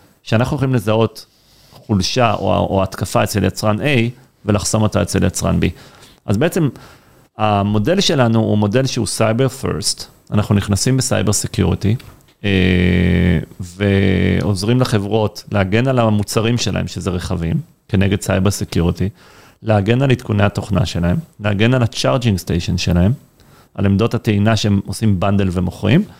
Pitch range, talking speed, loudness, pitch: 95-120 Hz, 130 wpm, -17 LUFS, 105 Hz